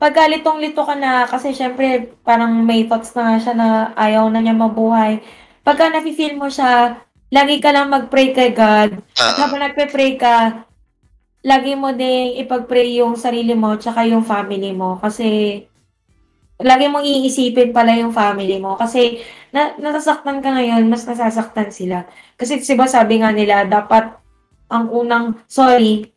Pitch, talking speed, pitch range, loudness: 235 Hz, 155 wpm, 225-265 Hz, -15 LUFS